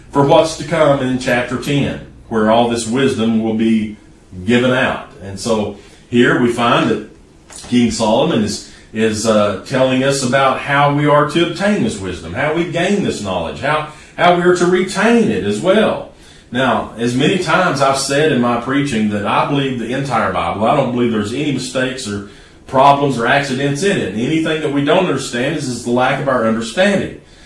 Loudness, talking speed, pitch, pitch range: -15 LUFS, 195 wpm, 130 Hz, 110-150 Hz